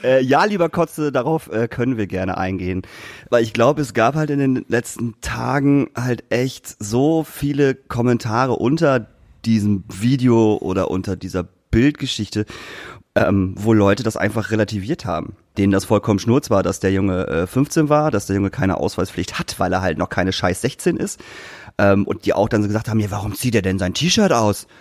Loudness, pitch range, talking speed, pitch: -19 LUFS, 100-130 Hz, 190 wpm, 110 Hz